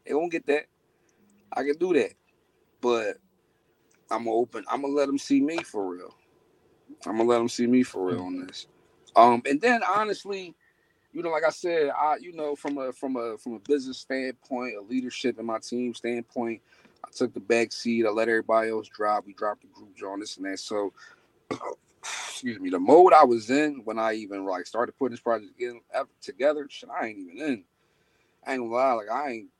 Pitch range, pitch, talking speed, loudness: 110-145 Hz, 120 Hz, 205 wpm, -26 LUFS